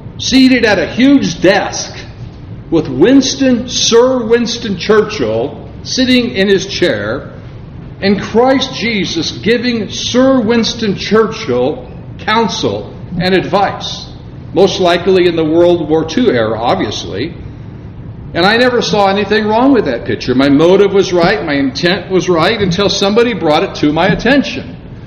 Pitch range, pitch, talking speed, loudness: 160-235 Hz, 195 Hz, 135 wpm, -11 LUFS